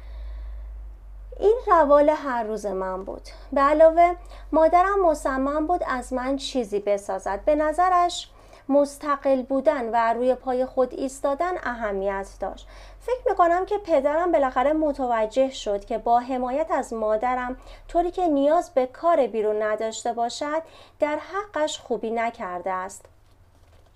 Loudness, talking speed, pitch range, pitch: -23 LUFS, 130 wpm, 220-315 Hz, 265 Hz